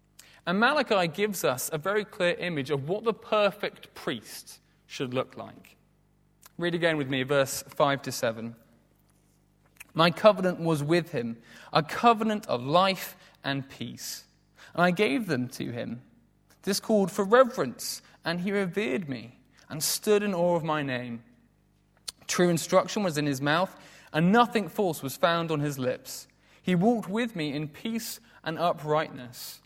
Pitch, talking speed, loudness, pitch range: 170 Hz, 160 wpm, -27 LUFS, 140-200 Hz